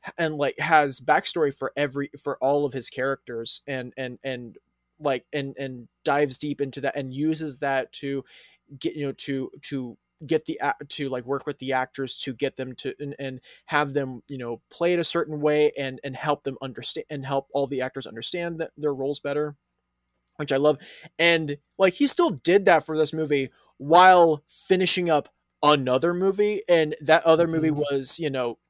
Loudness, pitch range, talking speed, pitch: -24 LUFS, 135-155 Hz, 190 wpm, 145 Hz